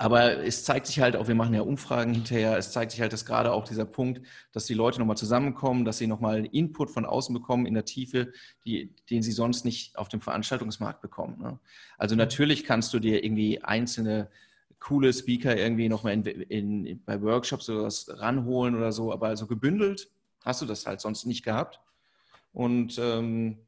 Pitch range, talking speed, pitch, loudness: 110-125 Hz, 200 wpm, 115 Hz, -28 LUFS